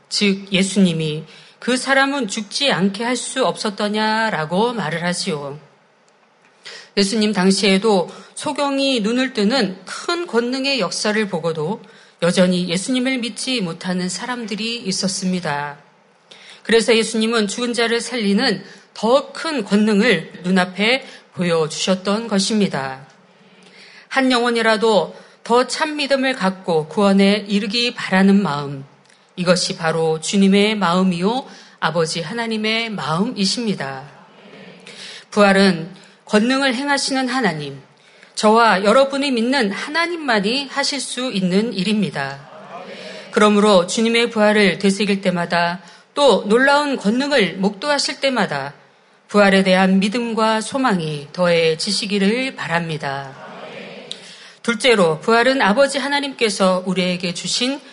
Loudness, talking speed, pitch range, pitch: -18 LUFS, 265 characters per minute, 185-235 Hz, 210 Hz